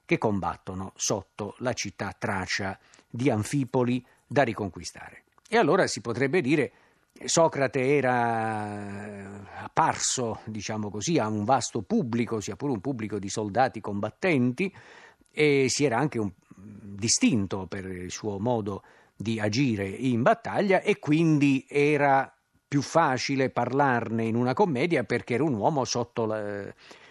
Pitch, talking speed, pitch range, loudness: 120 Hz, 135 wpm, 105-140 Hz, -26 LUFS